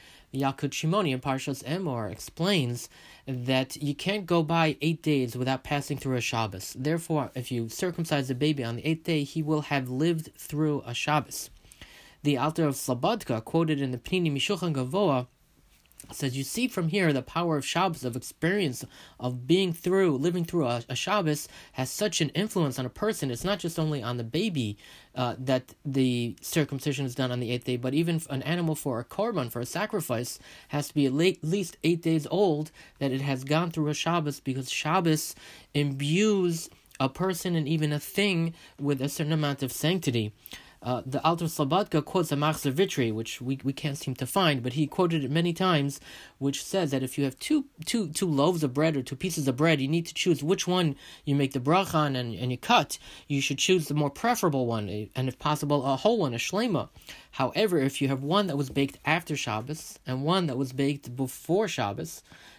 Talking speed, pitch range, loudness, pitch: 200 wpm, 130-165 Hz, -28 LUFS, 145 Hz